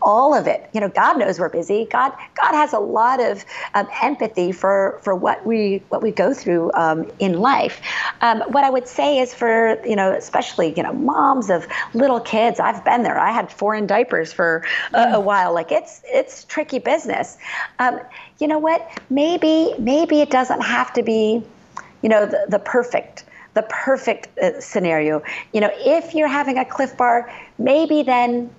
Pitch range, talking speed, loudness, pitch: 210-290 Hz, 190 wpm, -18 LUFS, 240 Hz